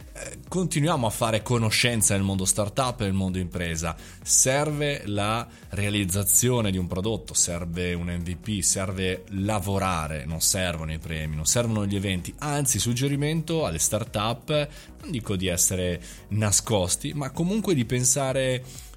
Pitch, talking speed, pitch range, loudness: 100 Hz, 135 wpm, 90-125 Hz, -25 LUFS